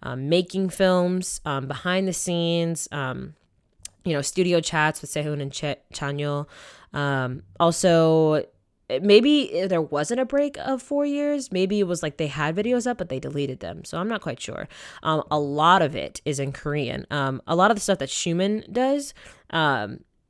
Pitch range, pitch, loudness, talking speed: 145-190 Hz, 165 Hz, -24 LUFS, 185 wpm